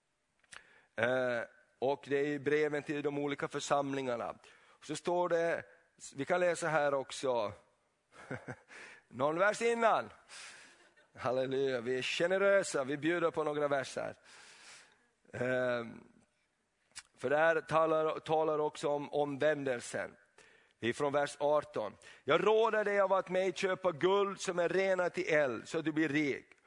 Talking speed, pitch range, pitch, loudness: 140 wpm, 145-180 Hz, 155 Hz, -33 LUFS